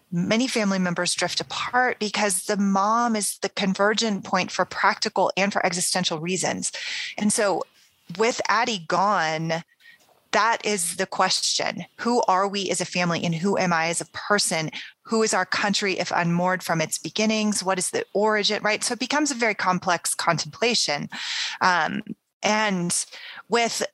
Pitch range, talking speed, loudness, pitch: 180-220 Hz, 160 wpm, -23 LUFS, 195 Hz